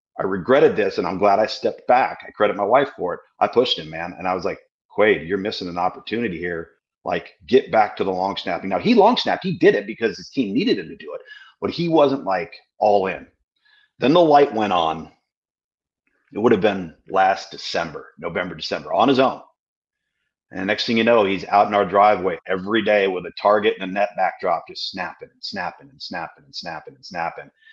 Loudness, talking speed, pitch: -20 LUFS, 225 wpm, 145 Hz